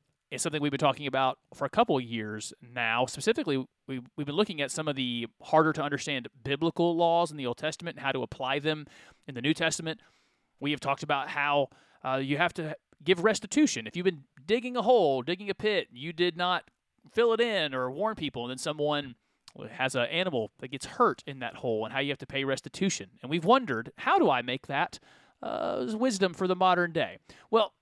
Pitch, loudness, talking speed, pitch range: 150 Hz, -29 LUFS, 220 wpm, 135-175 Hz